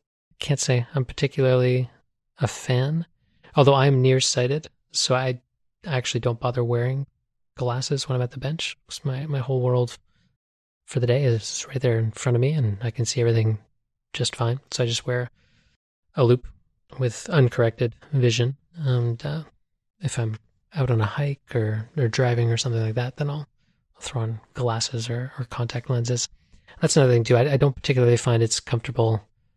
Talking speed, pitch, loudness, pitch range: 180 wpm, 125 Hz, -24 LUFS, 115-135 Hz